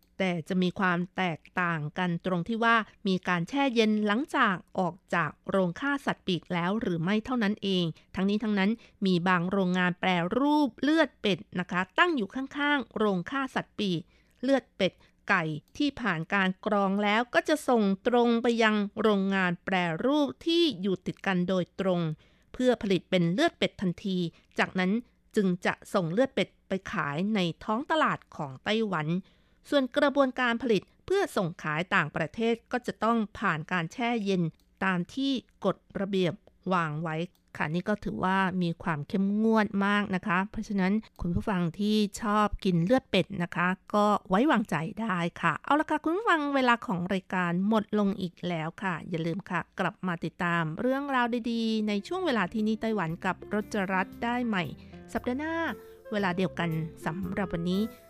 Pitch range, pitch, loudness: 180-230 Hz, 200 Hz, -28 LUFS